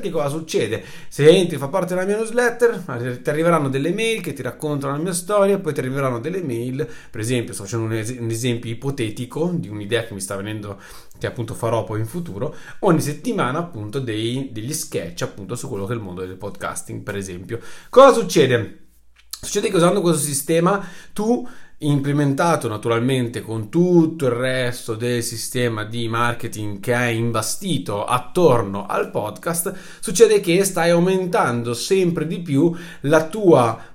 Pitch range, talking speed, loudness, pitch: 115-170 Hz, 170 wpm, -20 LUFS, 130 Hz